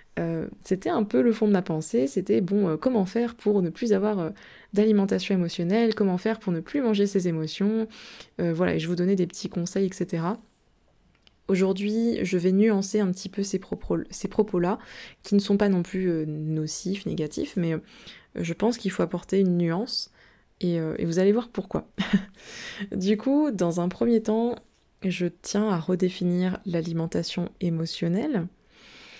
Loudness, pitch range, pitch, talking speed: -26 LUFS, 175-215 Hz, 195 Hz, 175 wpm